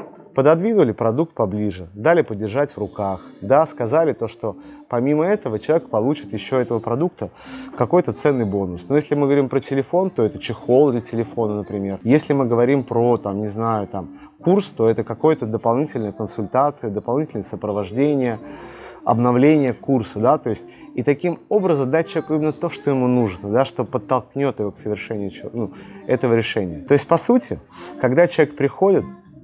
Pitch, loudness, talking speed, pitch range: 130 Hz, -20 LUFS, 165 wpm, 110-155 Hz